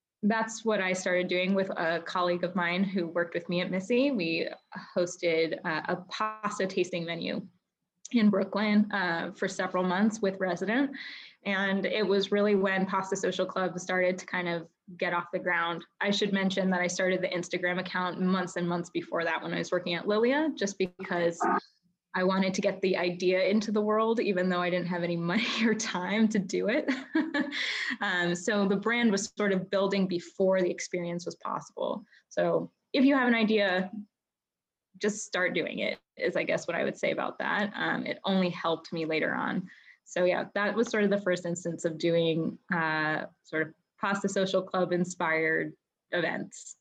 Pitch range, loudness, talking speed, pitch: 180-205 Hz, -29 LUFS, 185 wpm, 185 Hz